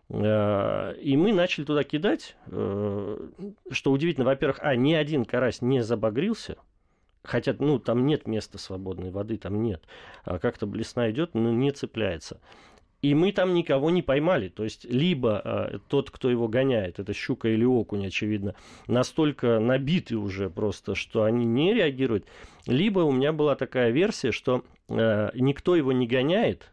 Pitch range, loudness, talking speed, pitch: 105-140 Hz, -26 LUFS, 150 wpm, 120 Hz